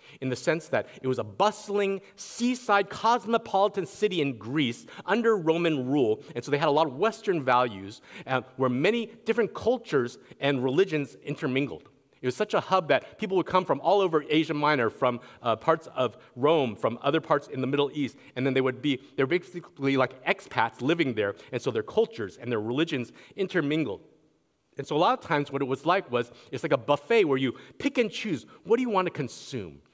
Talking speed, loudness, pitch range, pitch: 210 wpm, -27 LUFS, 130-200 Hz, 155 Hz